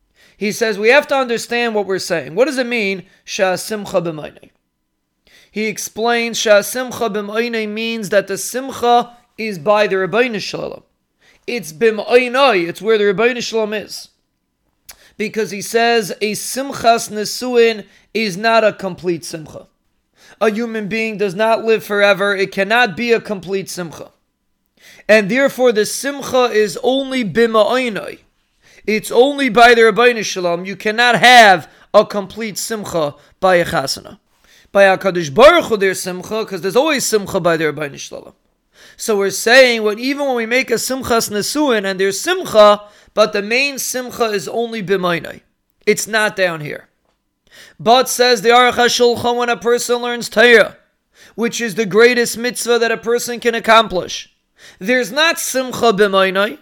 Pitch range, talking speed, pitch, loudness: 200-240 Hz, 150 wpm, 220 Hz, -15 LUFS